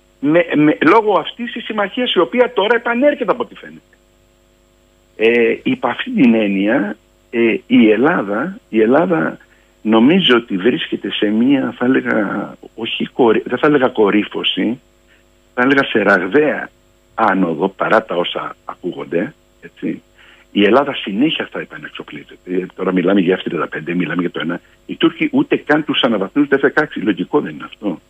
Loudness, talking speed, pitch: -15 LUFS, 150 wpm, 120 Hz